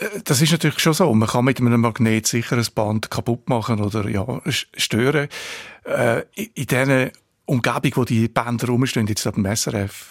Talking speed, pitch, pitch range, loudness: 180 wpm, 120 Hz, 110-135 Hz, -20 LUFS